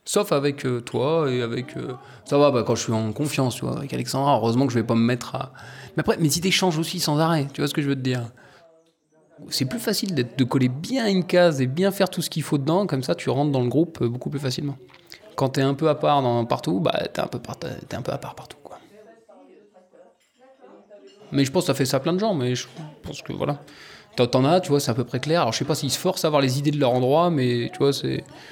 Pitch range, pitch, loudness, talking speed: 130-165 Hz, 140 Hz, -23 LUFS, 280 wpm